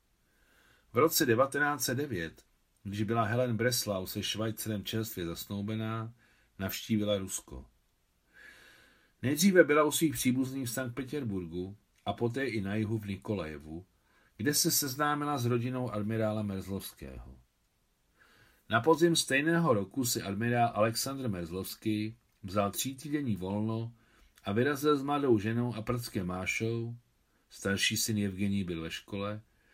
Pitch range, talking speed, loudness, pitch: 100-125 Hz, 125 wpm, -31 LUFS, 110 Hz